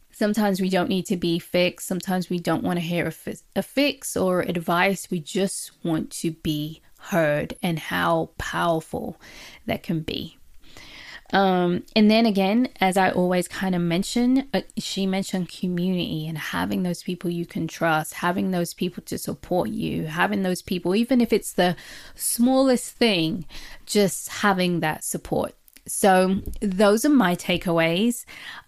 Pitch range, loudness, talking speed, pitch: 175-205 Hz, -23 LUFS, 160 wpm, 185 Hz